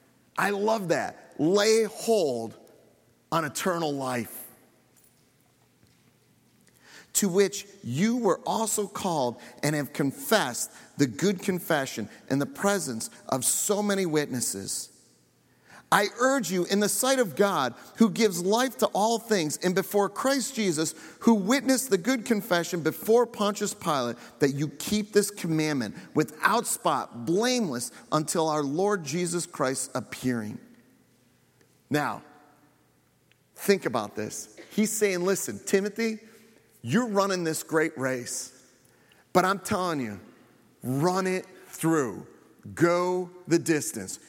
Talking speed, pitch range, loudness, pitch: 120 wpm, 130-205 Hz, -27 LUFS, 180 Hz